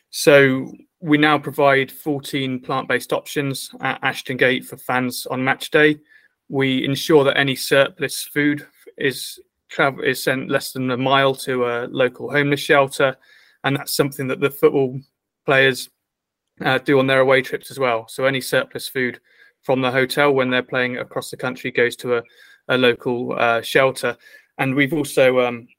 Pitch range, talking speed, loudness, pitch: 130-145 Hz, 170 wpm, -19 LUFS, 135 Hz